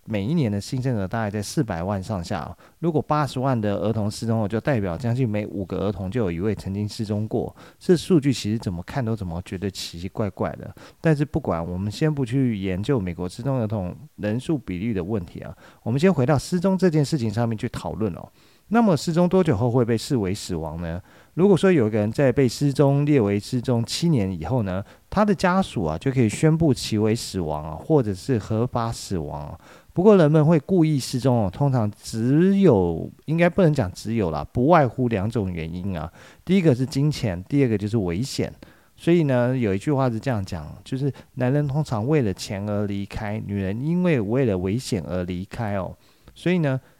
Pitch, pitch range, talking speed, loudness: 120 Hz, 100-145 Hz, 310 characters per minute, -23 LUFS